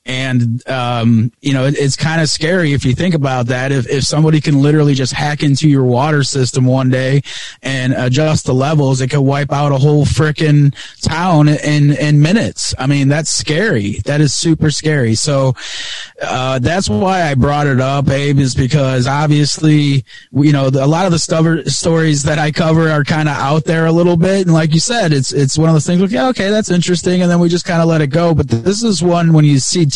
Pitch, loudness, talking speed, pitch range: 145 Hz, -13 LUFS, 230 wpm, 135-160 Hz